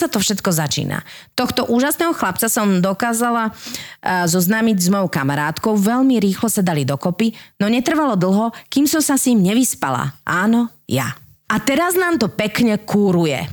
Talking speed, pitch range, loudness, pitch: 150 wpm, 185-245 Hz, -17 LUFS, 220 Hz